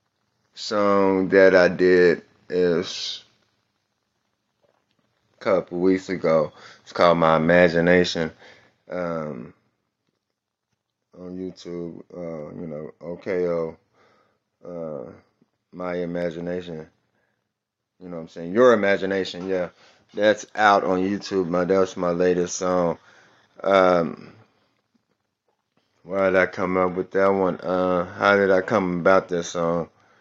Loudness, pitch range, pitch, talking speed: -21 LUFS, 85-95 Hz, 90 Hz, 120 wpm